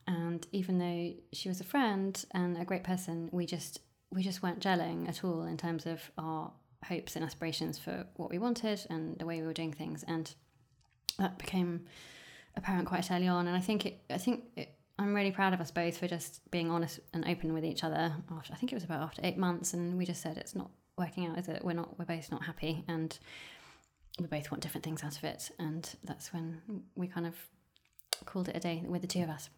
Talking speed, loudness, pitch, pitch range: 235 wpm, -37 LUFS, 170 Hz, 160-180 Hz